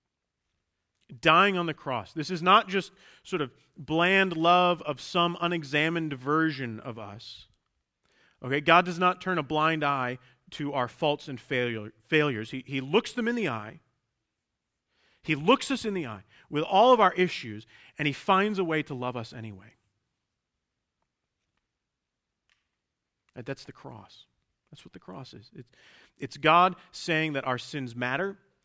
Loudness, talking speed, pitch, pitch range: -26 LUFS, 155 wpm, 145 Hz, 120-175 Hz